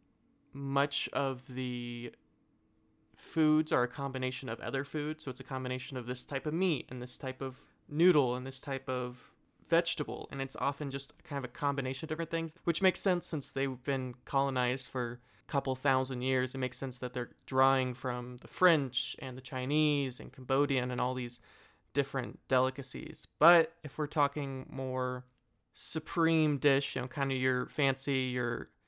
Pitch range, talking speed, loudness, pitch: 125-145 Hz, 175 wpm, -33 LUFS, 135 Hz